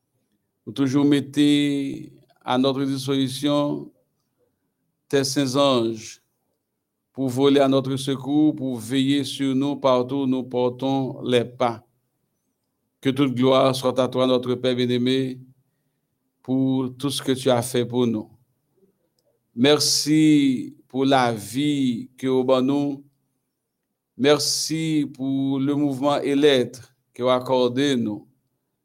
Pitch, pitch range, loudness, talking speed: 135 Hz, 125-140 Hz, -21 LUFS, 125 wpm